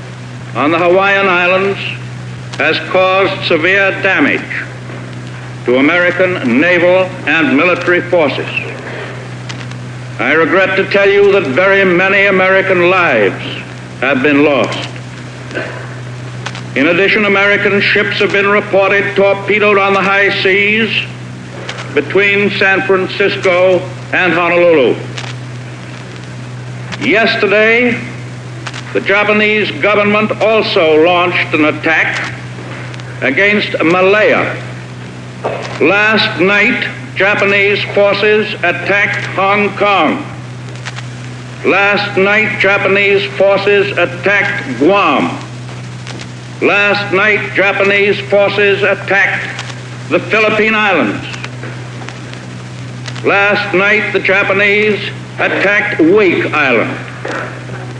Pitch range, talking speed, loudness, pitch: 125-200 Hz, 85 wpm, -10 LUFS, 180 Hz